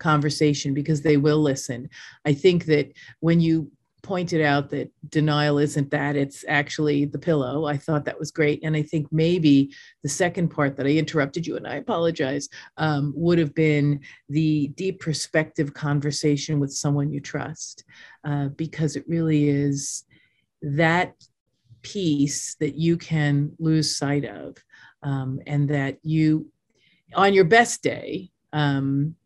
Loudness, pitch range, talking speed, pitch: -23 LUFS, 145-160 Hz, 150 wpm, 150 Hz